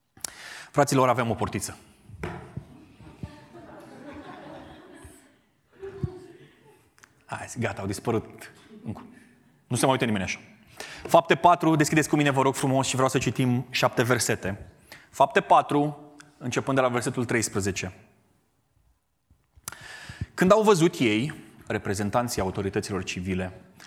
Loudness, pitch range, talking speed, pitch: -25 LUFS, 105-140 Hz, 105 wpm, 125 Hz